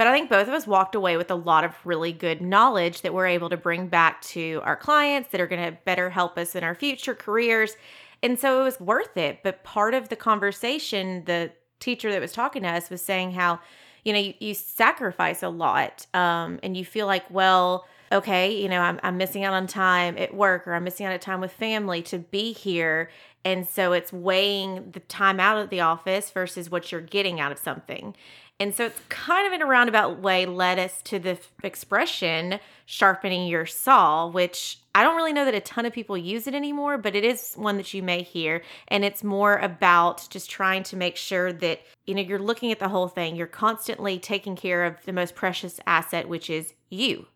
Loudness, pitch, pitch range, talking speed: -24 LUFS, 190 Hz, 175-210 Hz, 220 wpm